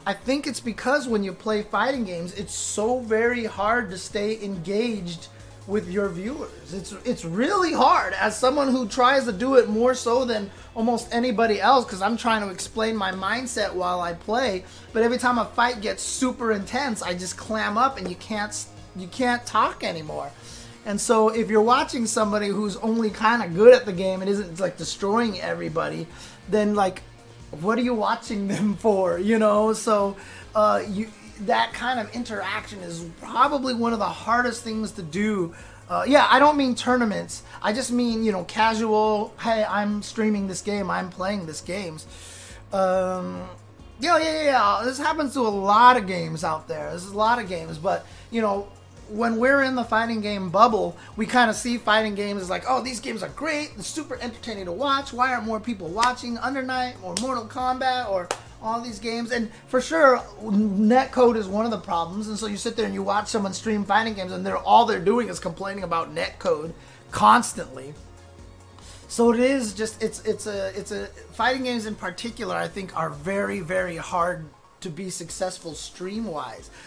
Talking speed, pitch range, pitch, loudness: 195 wpm, 190-240 Hz, 215 Hz, -23 LUFS